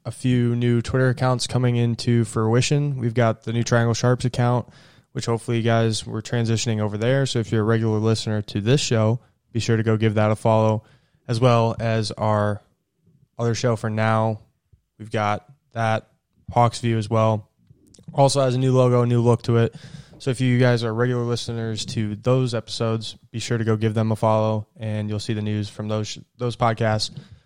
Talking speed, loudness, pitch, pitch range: 205 wpm, -22 LUFS, 115 Hz, 110-125 Hz